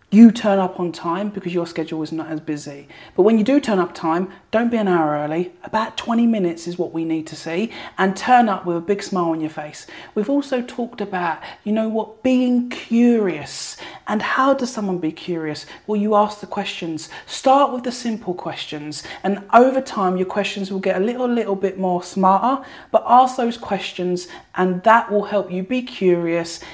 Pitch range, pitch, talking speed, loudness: 170-225 Hz, 195 Hz, 205 wpm, -20 LUFS